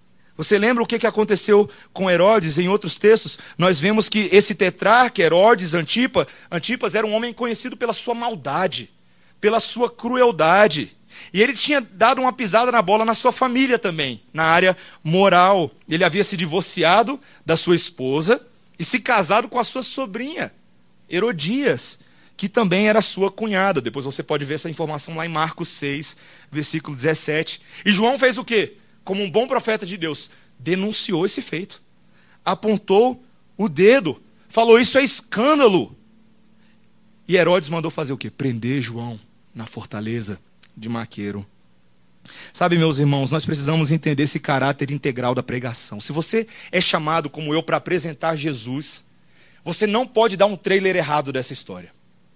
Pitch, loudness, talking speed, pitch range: 180 Hz, -19 LUFS, 155 wpm, 150-220 Hz